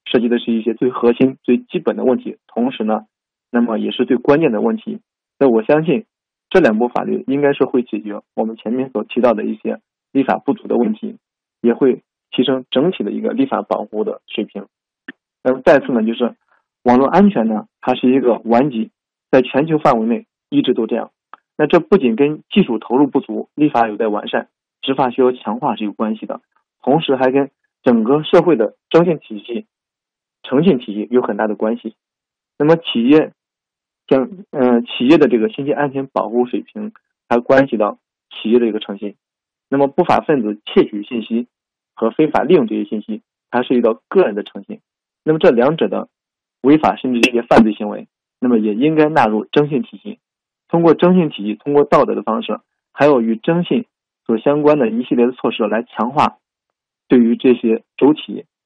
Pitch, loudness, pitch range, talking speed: 125 Hz, -16 LUFS, 115-150 Hz, 285 characters per minute